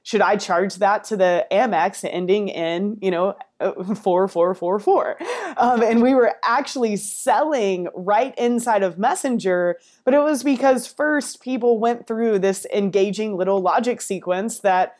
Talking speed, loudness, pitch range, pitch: 160 wpm, -20 LUFS, 185-245 Hz, 205 Hz